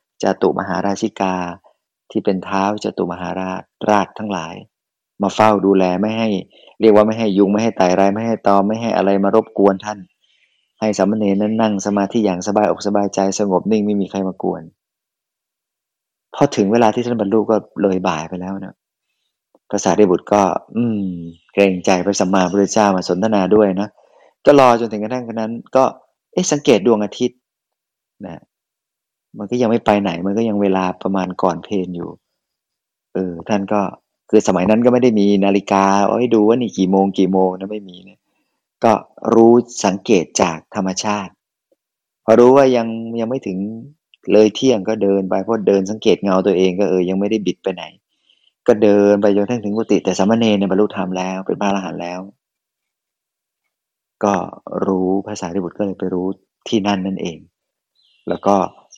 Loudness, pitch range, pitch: -16 LUFS, 95-110 Hz, 100 Hz